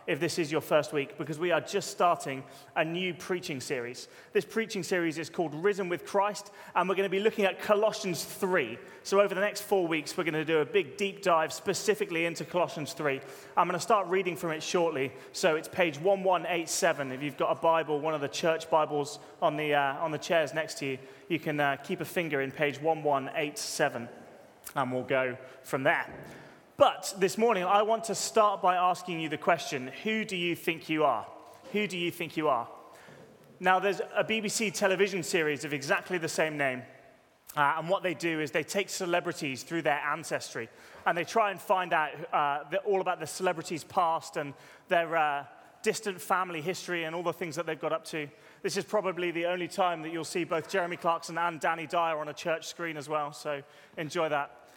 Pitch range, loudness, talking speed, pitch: 150-190 Hz, -30 LUFS, 220 wpm, 170 Hz